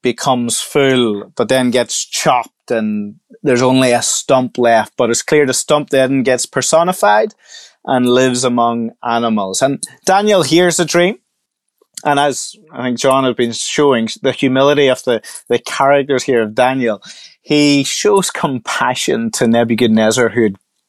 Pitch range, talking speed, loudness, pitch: 120-145 Hz, 150 wpm, -14 LUFS, 130 Hz